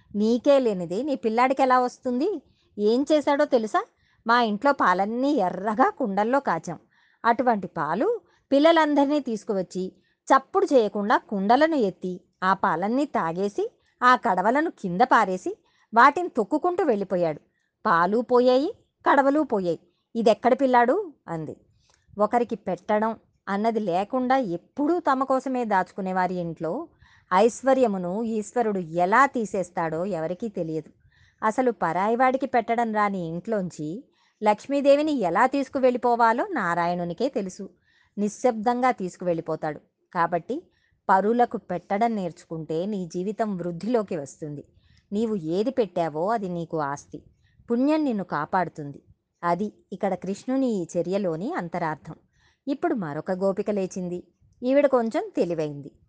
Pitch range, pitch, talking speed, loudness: 180-260 Hz, 220 Hz, 105 wpm, -24 LUFS